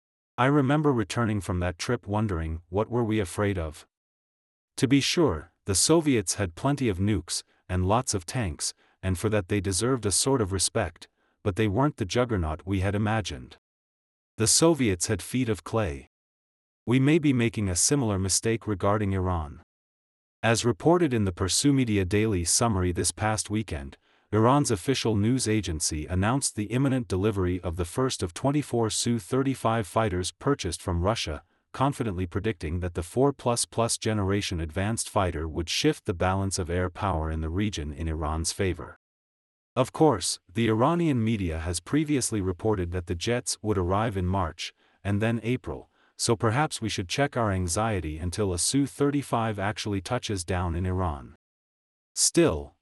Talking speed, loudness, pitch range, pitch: 160 wpm, -26 LUFS, 90-120 Hz, 105 Hz